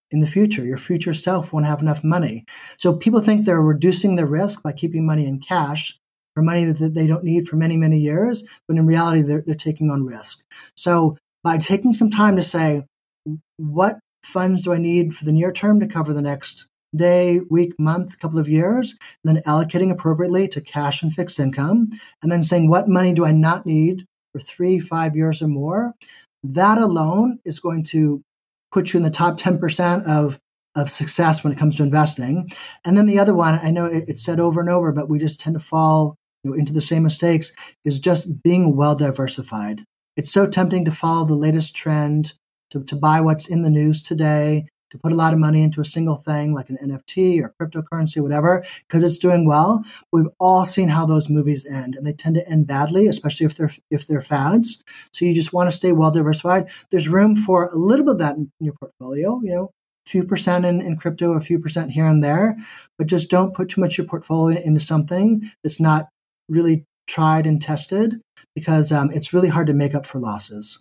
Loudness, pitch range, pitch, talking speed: -19 LUFS, 150-180 Hz, 160 Hz, 215 wpm